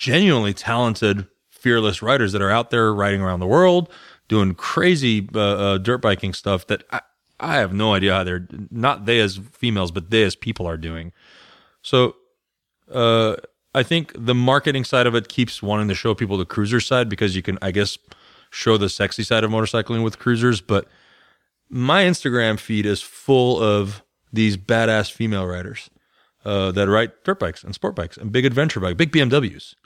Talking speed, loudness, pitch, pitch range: 185 wpm, -20 LUFS, 110 Hz, 100-125 Hz